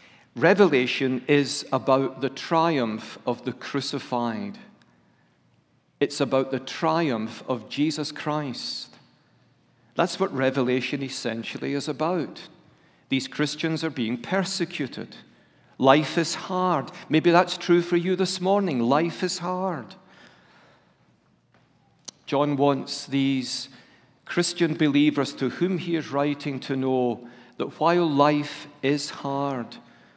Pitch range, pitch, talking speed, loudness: 130-165 Hz, 145 Hz, 110 wpm, -25 LUFS